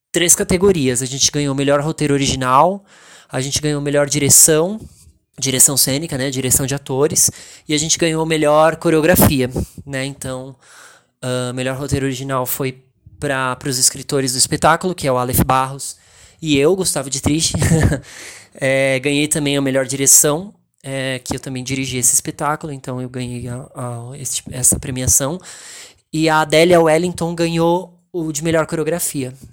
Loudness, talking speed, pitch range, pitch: -15 LUFS, 160 wpm, 130-155 Hz, 140 Hz